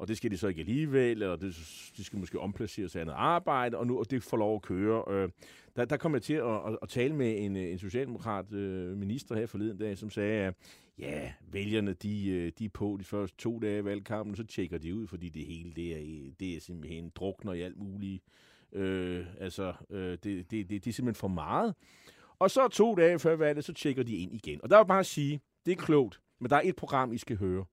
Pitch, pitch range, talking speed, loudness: 105 Hz, 95-120 Hz, 235 wpm, -32 LUFS